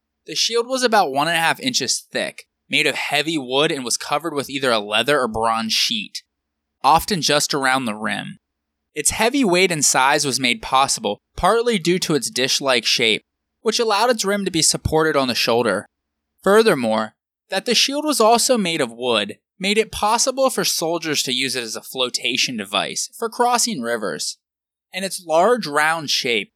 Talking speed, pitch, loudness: 180 wpm, 160 Hz, -19 LUFS